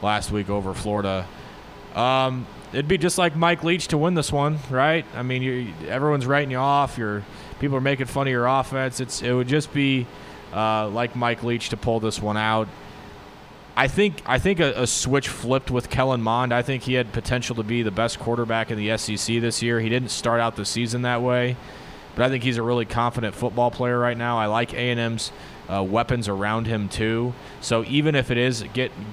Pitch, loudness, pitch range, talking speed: 120 Hz, -23 LUFS, 110-130 Hz, 210 wpm